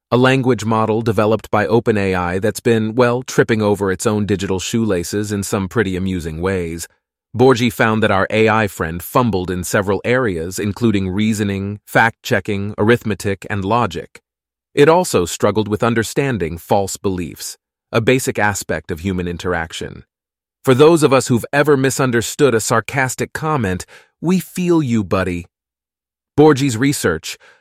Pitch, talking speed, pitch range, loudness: 110 Hz, 145 wpm, 95-120 Hz, -17 LUFS